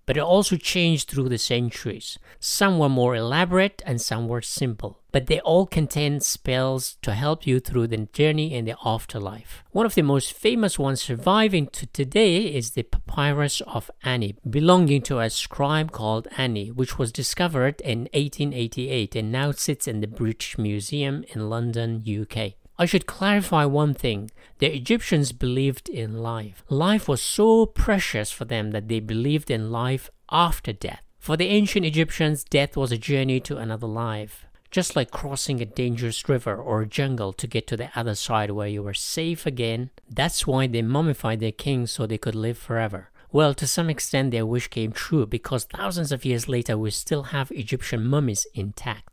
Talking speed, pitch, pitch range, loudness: 180 wpm, 130 Hz, 115-150 Hz, -24 LUFS